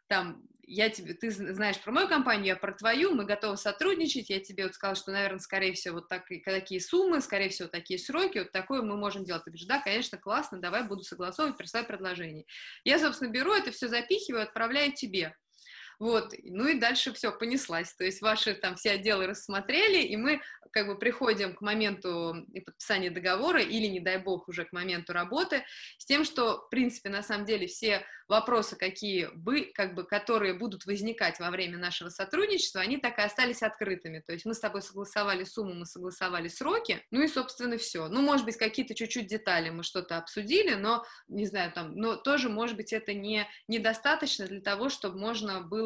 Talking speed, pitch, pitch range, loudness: 195 wpm, 210 Hz, 185-245 Hz, -31 LUFS